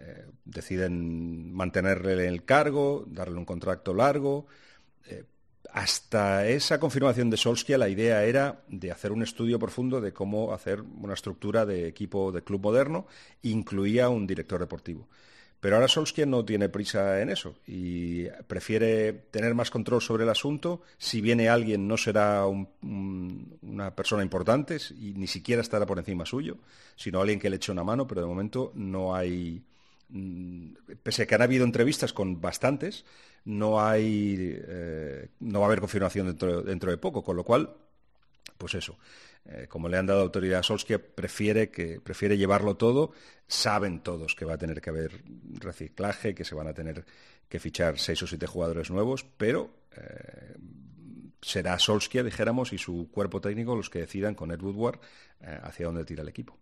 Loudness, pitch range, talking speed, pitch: -28 LUFS, 90-115 Hz, 170 wpm, 100 Hz